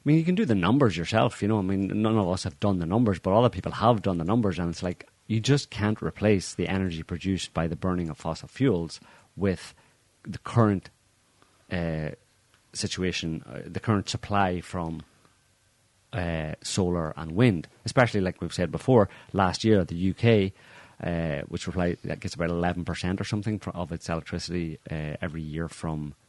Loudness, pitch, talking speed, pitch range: -27 LUFS, 95 Hz, 180 wpm, 85-110 Hz